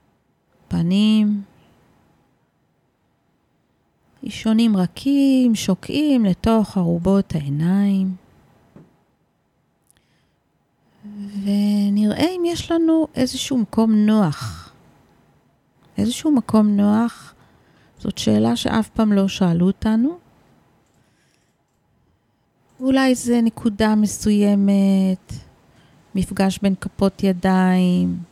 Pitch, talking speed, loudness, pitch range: 205 Hz, 65 wpm, -19 LUFS, 190-230 Hz